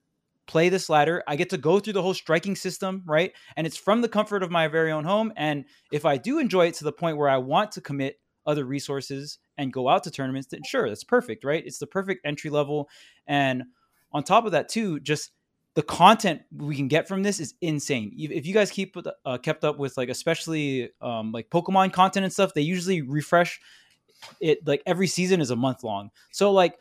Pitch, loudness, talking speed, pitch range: 160 Hz, -25 LUFS, 220 wpm, 145-190 Hz